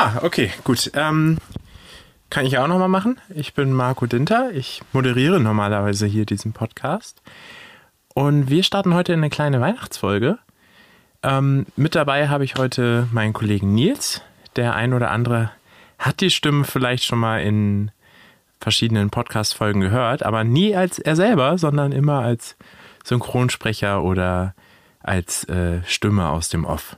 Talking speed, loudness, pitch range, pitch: 145 wpm, -20 LUFS, 105-145 Hz, 125 Hz